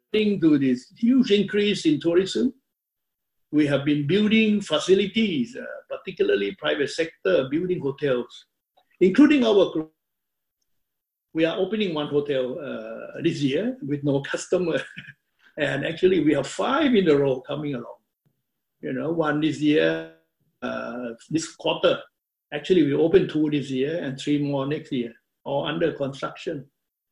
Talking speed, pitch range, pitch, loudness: 140 wpm, 140-205 Hz, 155 Hz, -23 LUFS